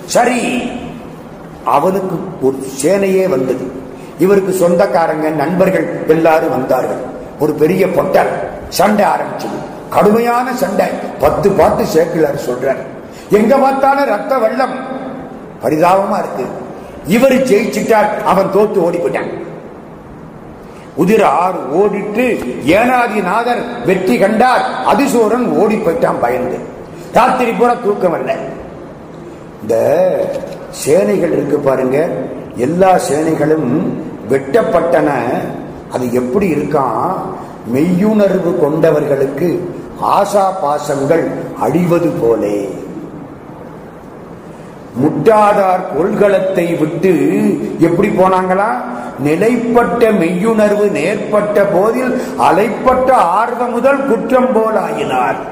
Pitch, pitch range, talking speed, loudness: 195 Hz, 165-235 Hz, 80 wpm, -13 LUFS